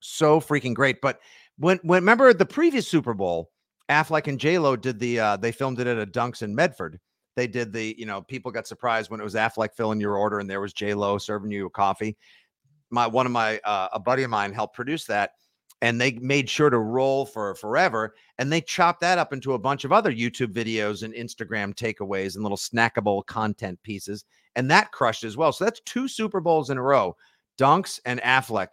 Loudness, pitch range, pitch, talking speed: -24 LUFS, 105-140 Hz, 120 Hz, 220 wpm